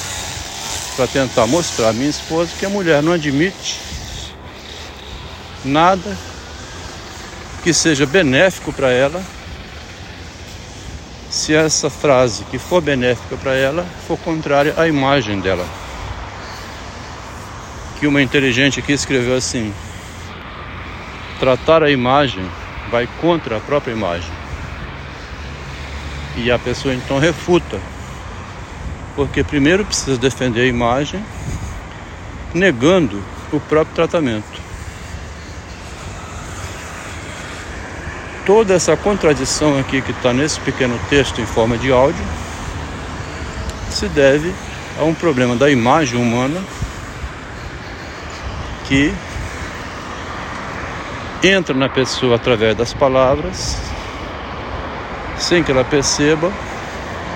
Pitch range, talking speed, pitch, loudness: 85-140 Hz, 95 wpm, 105 Hz, -17 LUFS